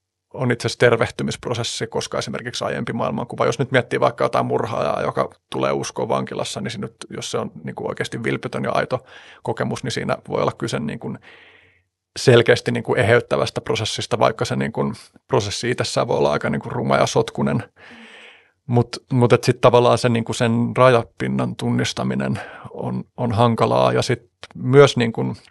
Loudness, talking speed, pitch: -20 LUFS, 160 wpm, 115 Hz